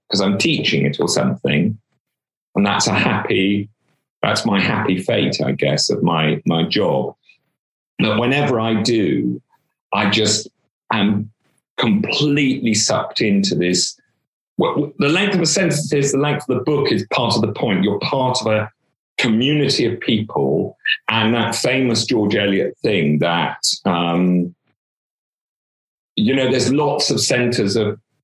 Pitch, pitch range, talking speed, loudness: 125 Hz, 105-145 Hz, 145 wpm, -17 LUFS